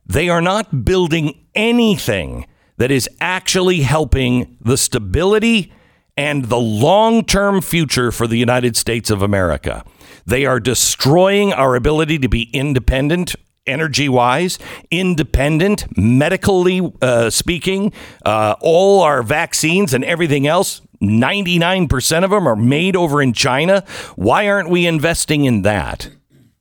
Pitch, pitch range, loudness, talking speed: 150 Hz, 125-185 Hz, -15 LUFS, 130 wpm